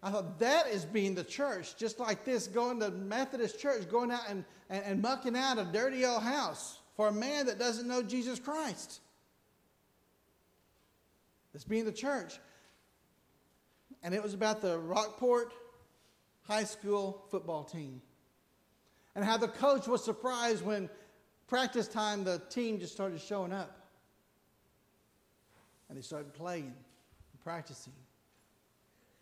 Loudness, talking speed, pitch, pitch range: -35 LUFS, 140 wpm, 215 Hz, 190-240 Hz